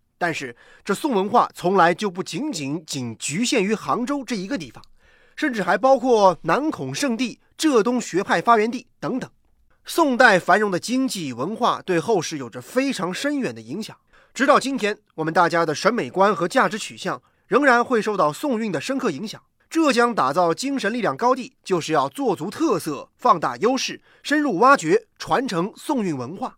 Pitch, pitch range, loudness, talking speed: 215 Hz, 175-260 Hz, -21 LUFS, 275 characters per minute